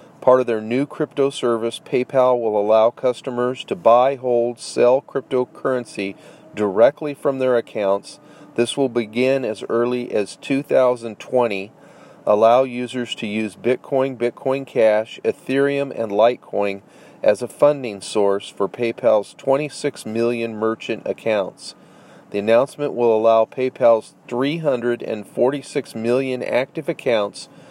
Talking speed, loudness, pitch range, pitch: 120 wpm, -20 LUFS, 115-135 Hz, 125 Hz